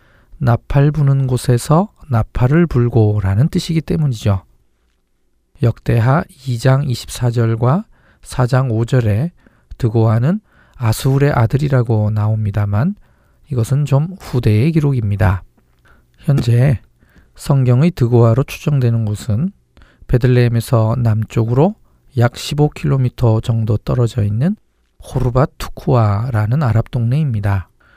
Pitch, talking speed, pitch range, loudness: 120 Hz, 235 characters per minute, 110-140 Hz, -16 LUFS